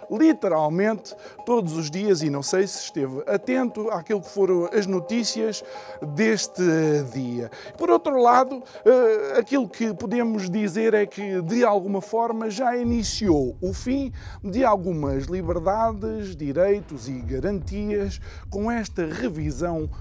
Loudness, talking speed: -23 LUFS, 125 wpm